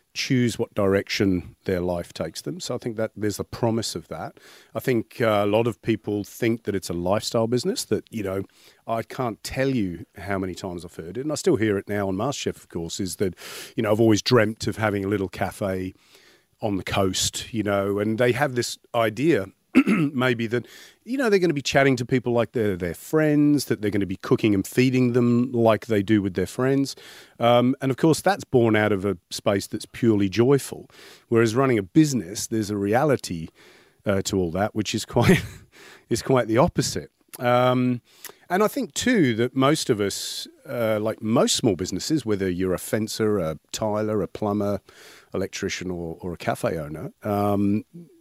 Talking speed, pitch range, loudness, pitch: 205 wpm, 100-125 Hz, -24 LUFS, 110 Hz